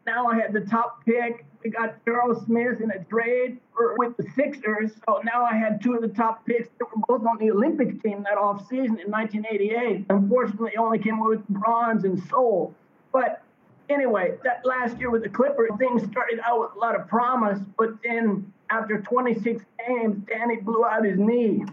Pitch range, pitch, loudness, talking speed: 215-240 Hz, 230 Hz, -24 LUFS, 190 wpm